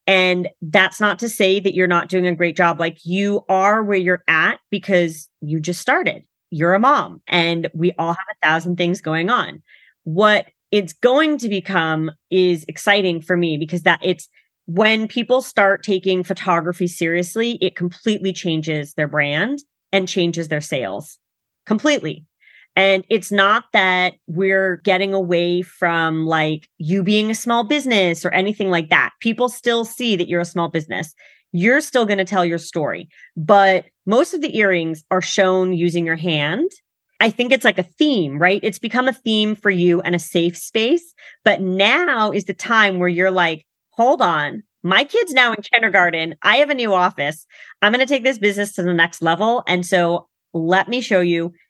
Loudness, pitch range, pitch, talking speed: -18 LUFS, 170-215 Hz, 185 Hz, 185 wpm